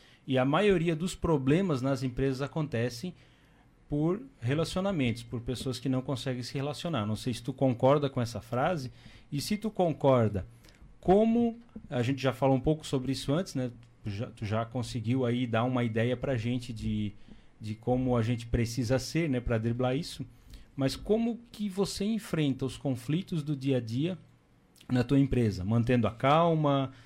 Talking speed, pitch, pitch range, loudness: 175 wpm, 130 Hz, 120-155 Hz, -30 LUFS